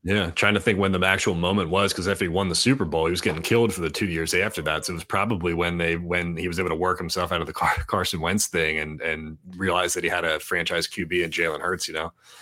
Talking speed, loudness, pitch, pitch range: 290 wpm, -24 LUFS, 90 Hz, 85-95 Hz